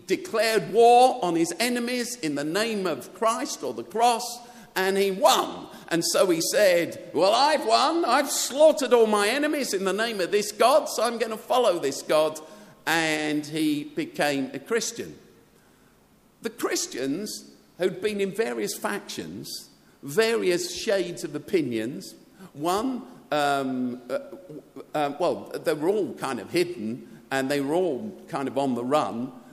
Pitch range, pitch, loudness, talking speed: 160-245 Hz, 210 Hz, -25 LUFS, 155 wpm